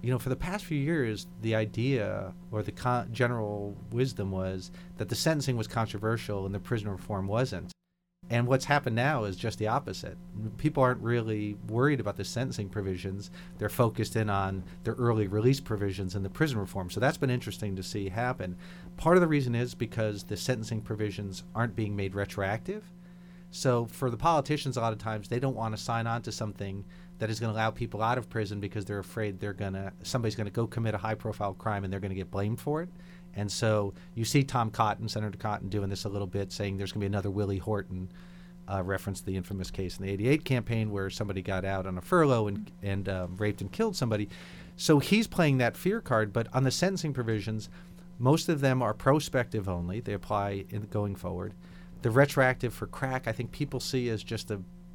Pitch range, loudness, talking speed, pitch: 100-125 Hz, -31 LUFS, 215 wpm, 110 Hz